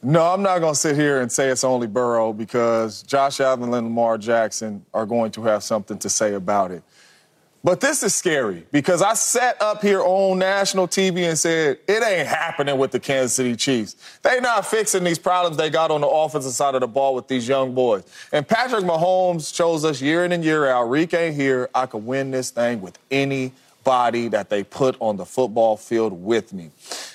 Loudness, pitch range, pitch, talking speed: -20 LUFS, 120-170 Hz, 135 Hz, 210 wpm